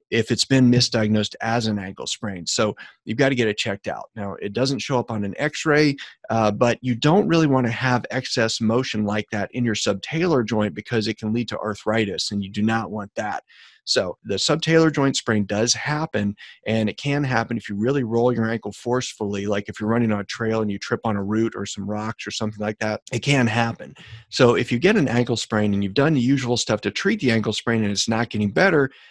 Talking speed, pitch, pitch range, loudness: 240 wpm, 115 Hz, 105-125 Hz, -22 LUFS